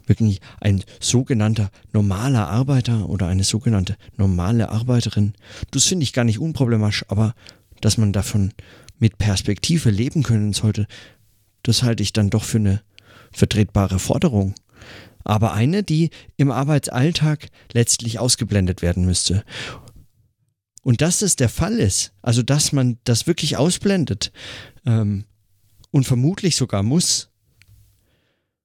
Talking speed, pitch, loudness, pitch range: 130 wpm, 110 Hz, -20 LUFS, 100-125 Hz